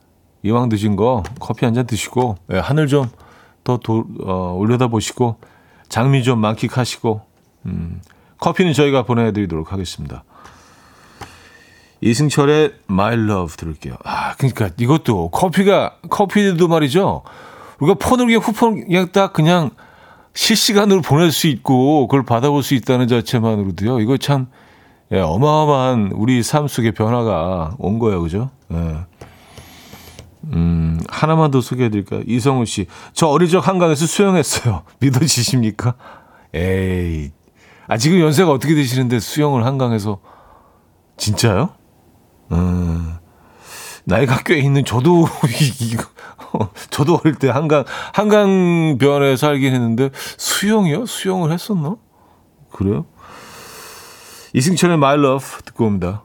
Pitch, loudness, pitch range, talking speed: 125 Hz, -16 LUFS, 105-155 Hz, 270 characters per minute